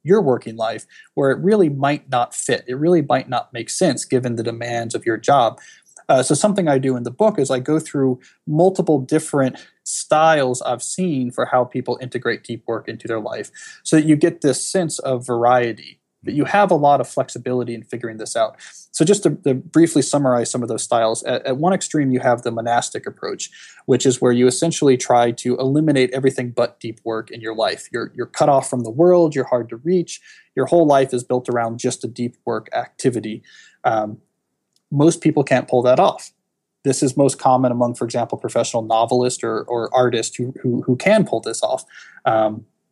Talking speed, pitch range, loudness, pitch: 210 wpm, 120-150 Hz, -19 LUFS, 130 Hz